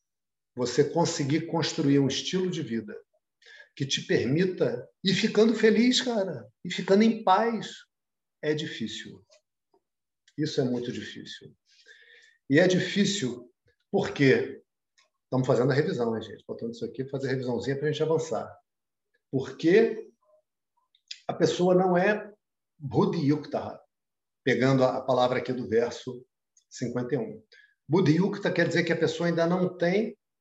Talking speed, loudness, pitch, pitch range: 130 wpm, -26 LUFS, 170 Hz, 135-210 Hz